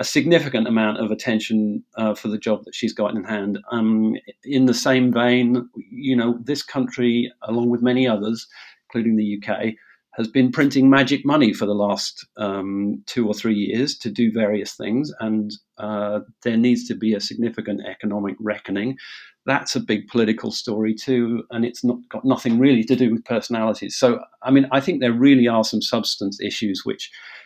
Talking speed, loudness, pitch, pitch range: 185 wpm, -21 LUFS, 115 Hz, 110-125 Hz